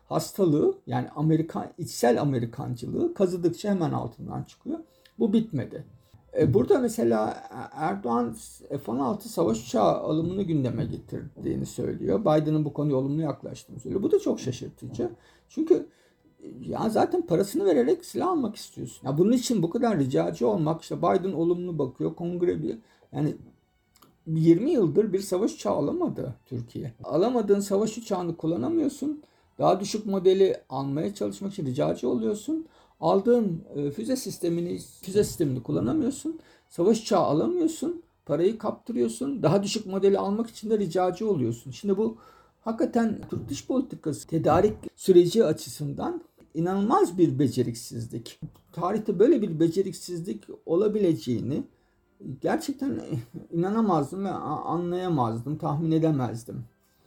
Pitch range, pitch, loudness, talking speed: 150-220 Hz, 180 Hz, -26 LUFS, 120 wpm